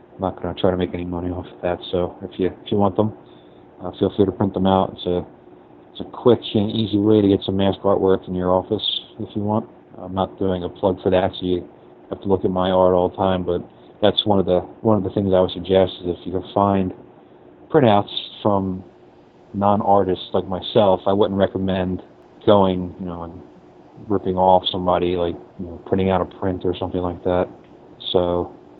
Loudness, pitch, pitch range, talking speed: -20 LUFS, 95 Hz, 90-100 Hz, 225 wpm